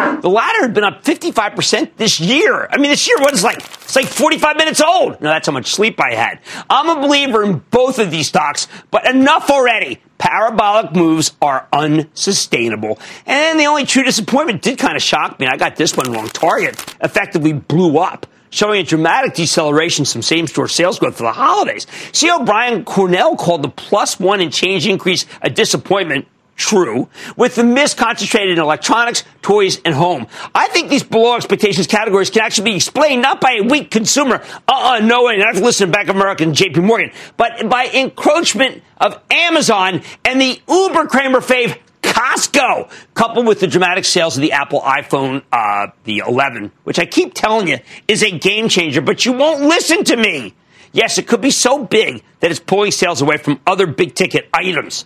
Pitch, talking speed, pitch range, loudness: 210 Hz, 195 wpm, 170-255 Hz, -13 LUFS